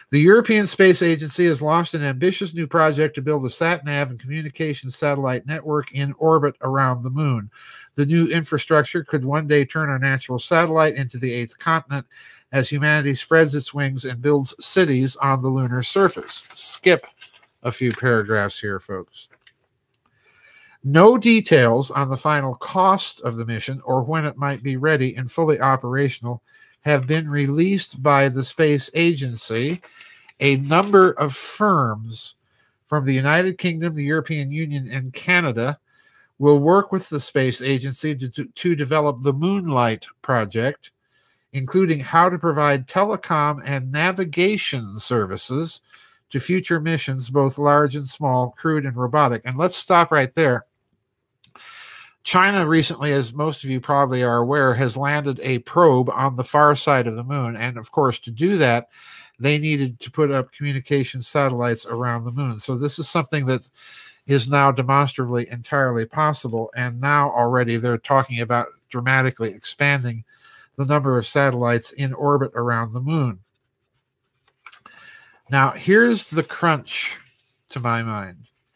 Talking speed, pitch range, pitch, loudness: 150 wpm, 130-160 Hz, 140 Hz, -20 LUFS